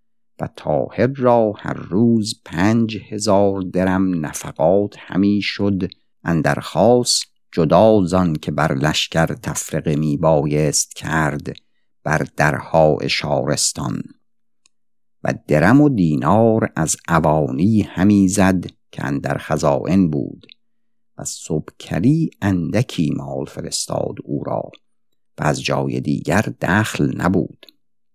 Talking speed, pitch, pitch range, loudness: 105 wpm, 95 Hz, 80-110 Hz, -18 LUFS